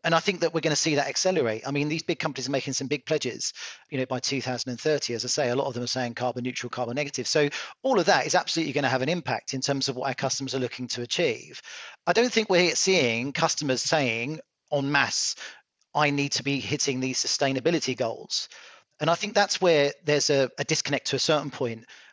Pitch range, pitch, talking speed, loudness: 130-155 Hz, 140 Hz, 245 wpm, -26 LUFS